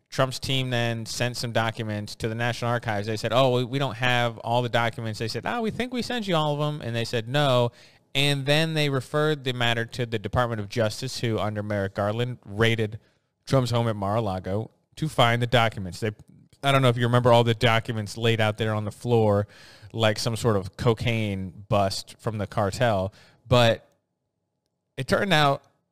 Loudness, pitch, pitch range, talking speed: -25 LUFS, 120 Hz, 110-130 Hz, 205 wpm